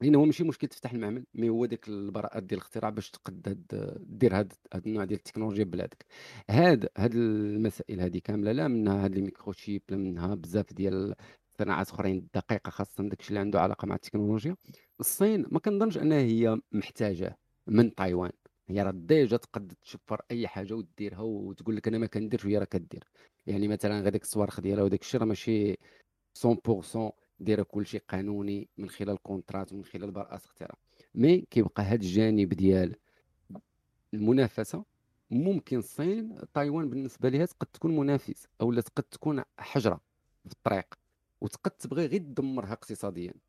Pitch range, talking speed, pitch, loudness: 100-120 Hz, 155 wpm, 105 Hz, -30 LUFS